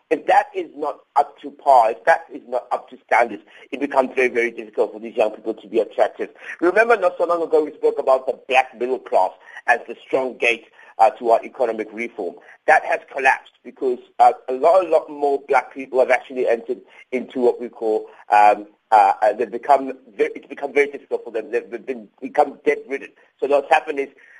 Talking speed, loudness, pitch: 210 wpm, -20 LUFS, 140 Hz